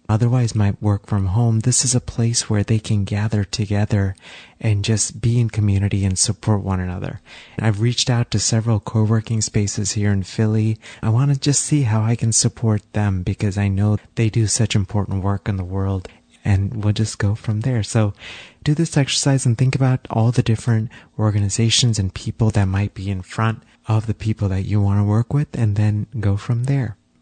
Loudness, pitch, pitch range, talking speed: -19 LUFS, 110 Hz, 100-115 Hz, 205 wpm